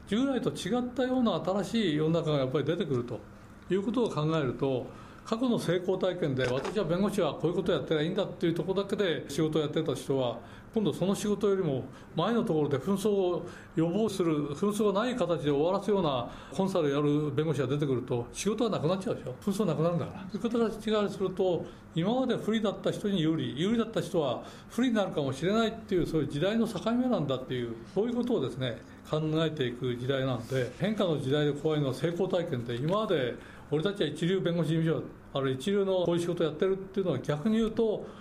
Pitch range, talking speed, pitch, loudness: 145-205 Hz, 465 characters per minute, 170 Hz, -30 LUFS